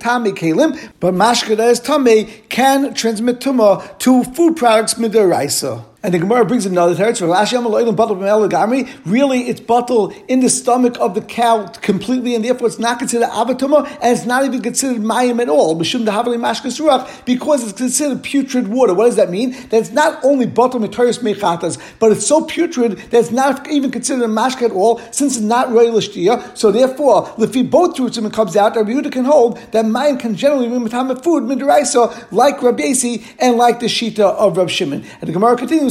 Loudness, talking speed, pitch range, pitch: -15 LUFS, 185 wpm, 220-255 Hz, 240 Hz